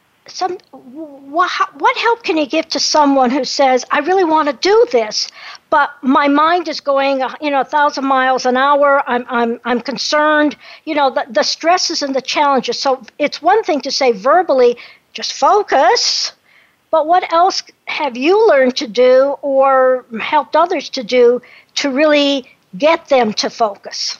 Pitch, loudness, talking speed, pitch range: 285 Hz, -14 LUFS, 170 wpm, 260-320 Hz